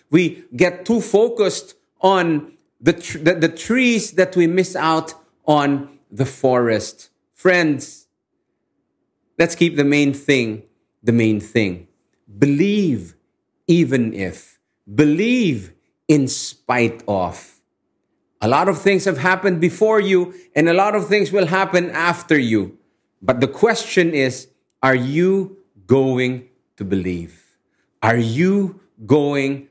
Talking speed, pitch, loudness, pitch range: 125 wpm, 160 Hz, -18 LUFS, 130-185 Hz